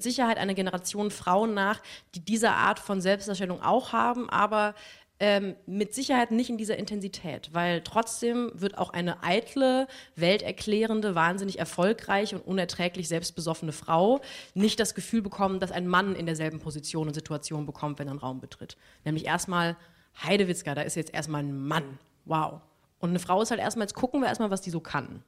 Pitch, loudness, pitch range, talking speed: 190 Hz, -28 LUFS, 165-215 Hz, 180 wpm